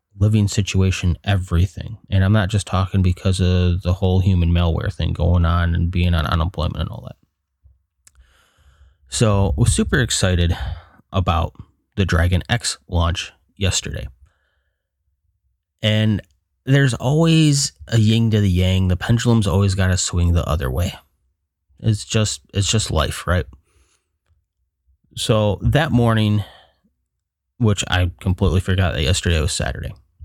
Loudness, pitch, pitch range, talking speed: -19 LUFS, 90 Hz, 80-105 Hz, 135 wpm